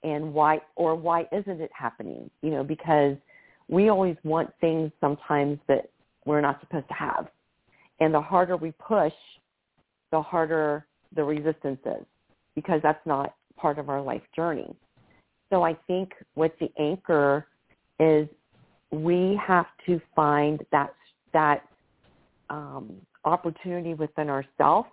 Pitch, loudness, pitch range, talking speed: 155 Hz, -26 LUFS, 150-170 Hz, 135 wpm